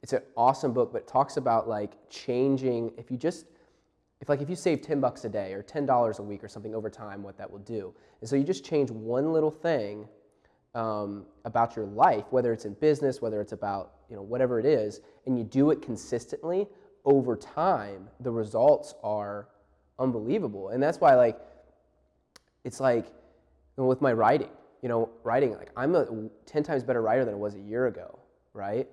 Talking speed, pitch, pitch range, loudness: 195 wpm, 115 Hz, 105-135 Hz, -28 LUFS